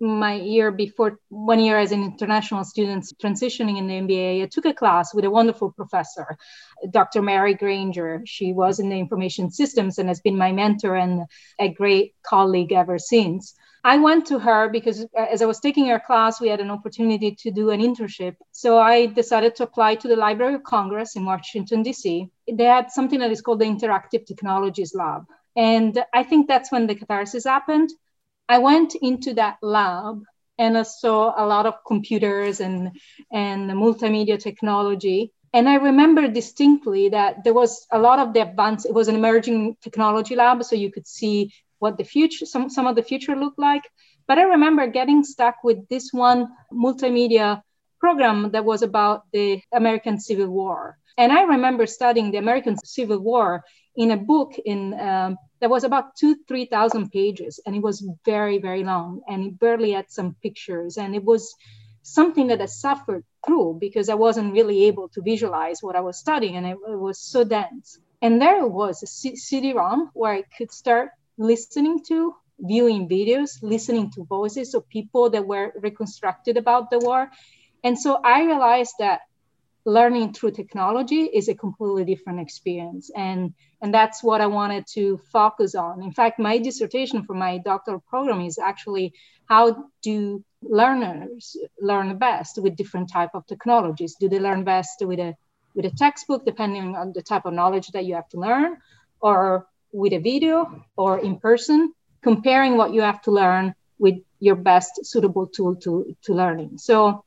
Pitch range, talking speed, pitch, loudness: 195-240 Hz, 180 wpm, 215 Hz, -21 LUFS